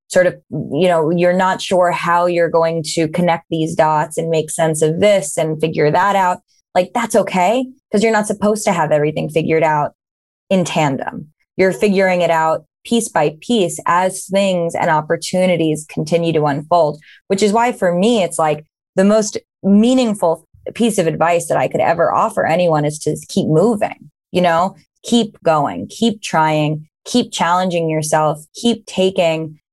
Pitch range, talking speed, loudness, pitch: 160-195 Hz, 175 wpm, -16 LUFS, 170 Hz